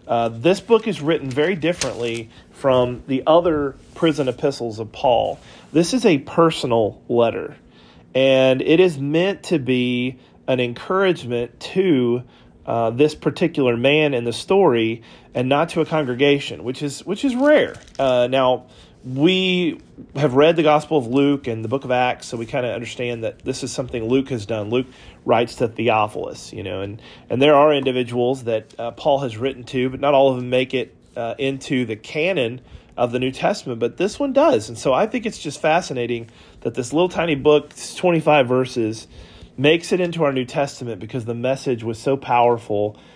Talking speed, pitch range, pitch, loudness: 190 wpm, 120-155 Hz, 130 Hz, -20 LUFS